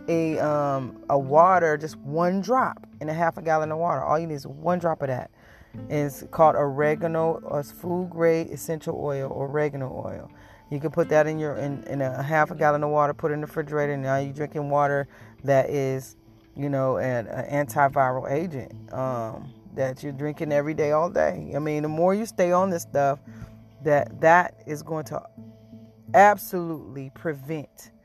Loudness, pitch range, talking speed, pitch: -24 LUFS, 130-160 Hz, 195 wpm, 145 Hz